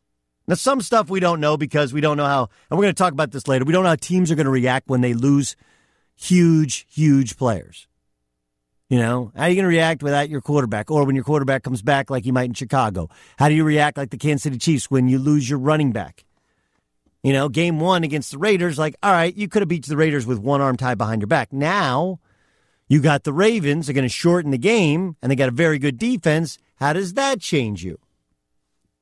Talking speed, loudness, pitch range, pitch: 240 wpm, -19 LUFS, 125-165 Hz, 145 Hz